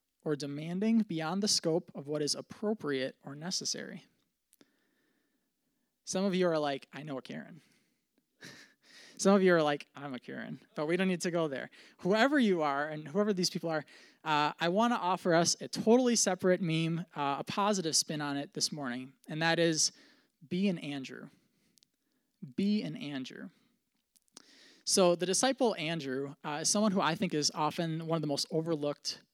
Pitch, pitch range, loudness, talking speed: 175 Hz, 150-215 Hz, -31 LUFS, 180 wpm